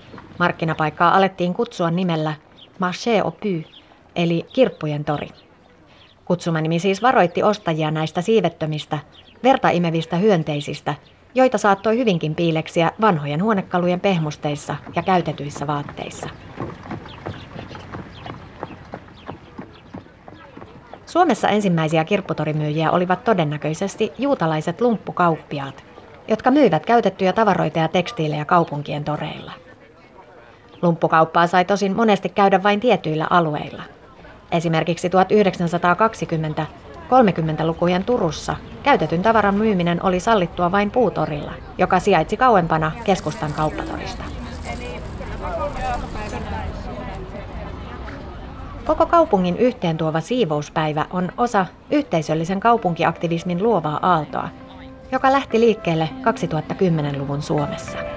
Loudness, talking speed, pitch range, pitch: -20 LUFS, 85 wpm, 155-205 Hz, 175 Hz